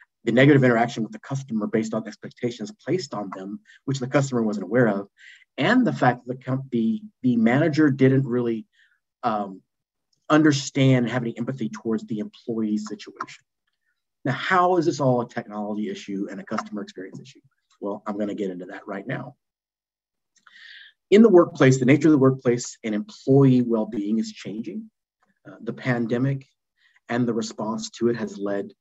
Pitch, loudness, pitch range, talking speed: 120 Hz, -23 LUFS, 105-135 Hz, 175 wpm